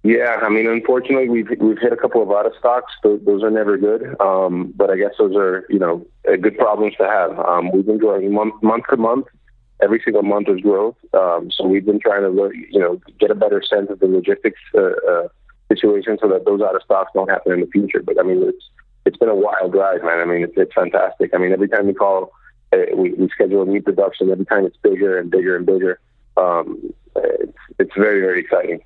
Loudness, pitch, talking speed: -17 LUFS, 310 Hz, 235 wpm